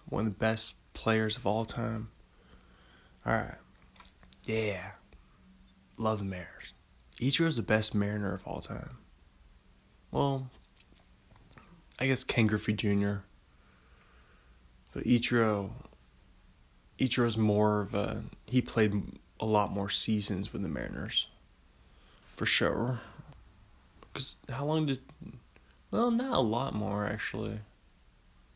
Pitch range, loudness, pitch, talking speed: 95-115 Hz, -32 LUFS, 105 Hz, 115 wpm